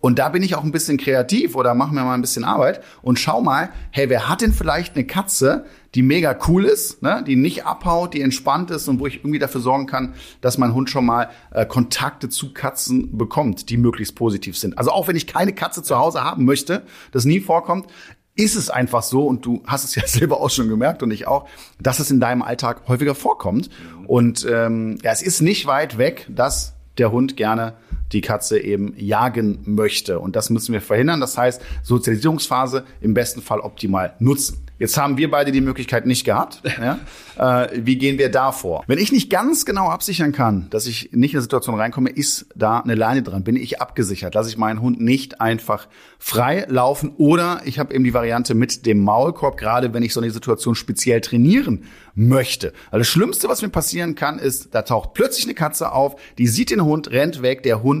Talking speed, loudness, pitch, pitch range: 215 wpm, -19 LUFS, 130 Hz, 115-145 Hz